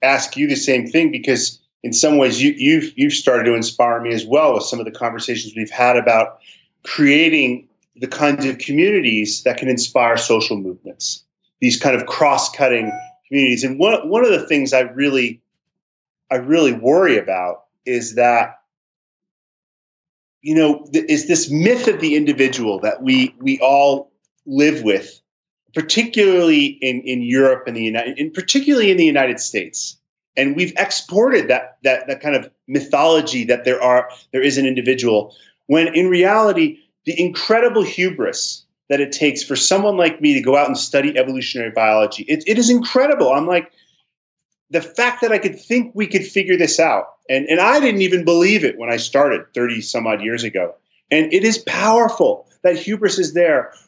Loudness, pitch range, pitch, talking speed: -16 LUFS, 125-210 Hz, 150 Hz, 175 wpm